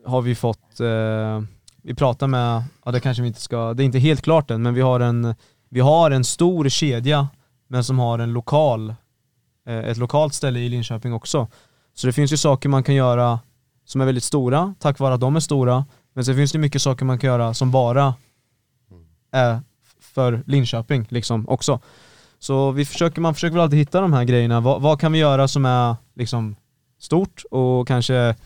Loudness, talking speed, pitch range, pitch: -20 LUFS, 200 wpm, 120-140 Hz, 130 Hz